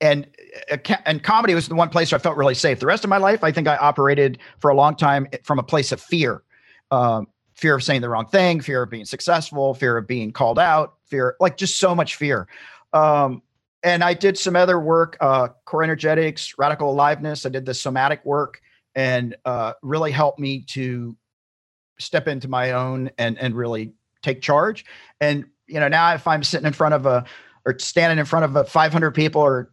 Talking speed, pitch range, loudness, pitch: 210 wpm, 125-160 Hz, -20 LUFS, 145 Hz